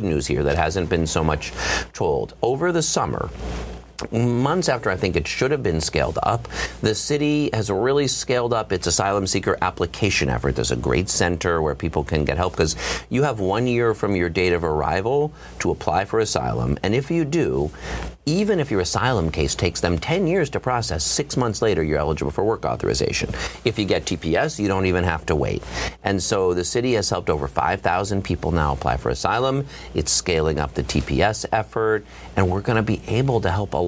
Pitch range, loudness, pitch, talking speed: 80-115 Hz, -22 LUFS, 95 Hz, 205 wpm